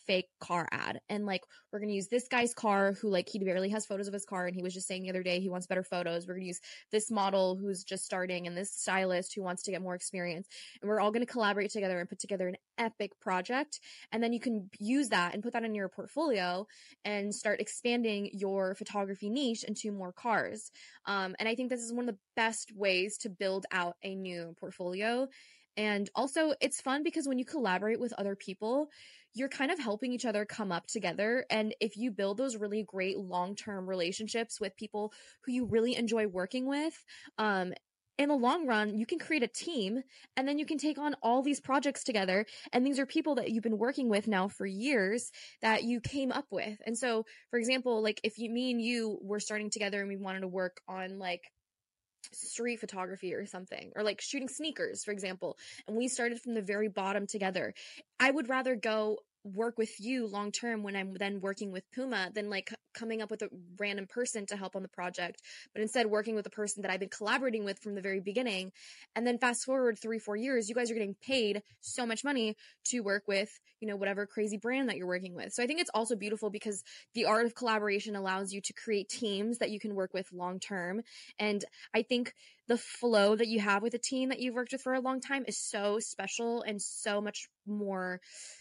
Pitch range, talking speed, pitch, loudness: 195-240 Hz, 225 wpm, 215 Hz, -34 LUFS